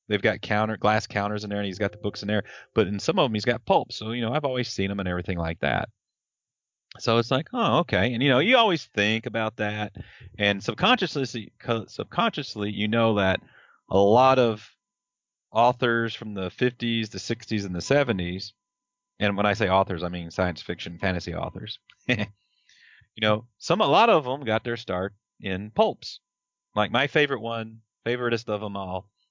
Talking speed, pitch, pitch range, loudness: 195 wpm, 110 Hz, 100-125 Hz, -25 LUFS